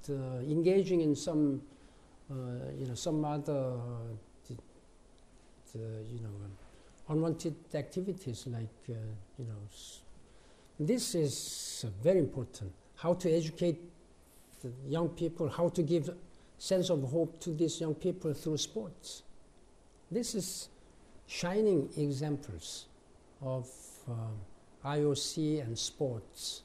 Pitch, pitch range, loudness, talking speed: 145 Hz, 115-165 Hz, -35 LUFS, 125 wpm